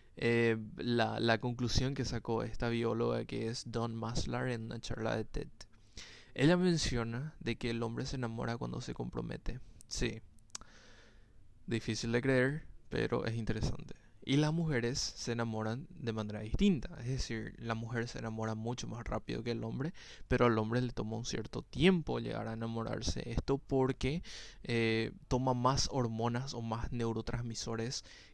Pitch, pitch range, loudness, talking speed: 115 Hz, 110-125 Hz, -36 LUFS, 160 wpm